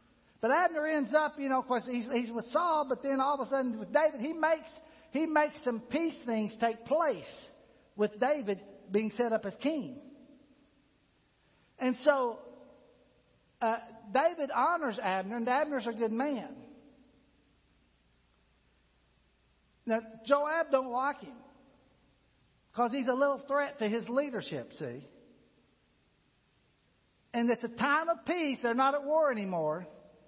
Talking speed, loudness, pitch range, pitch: 140 wpm, -32 LUFS, 225-285 Hz, 260 Hz